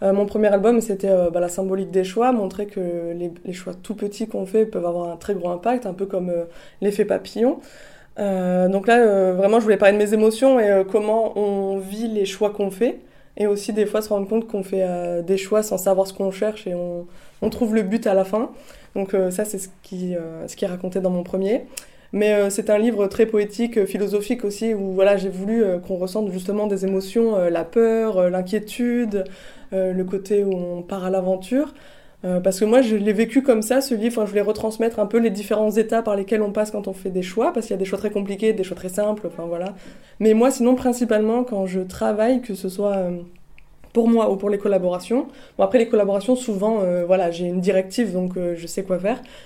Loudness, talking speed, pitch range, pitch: -21 LUFS, 240 wpm, 190-220 Hz, 205 Hz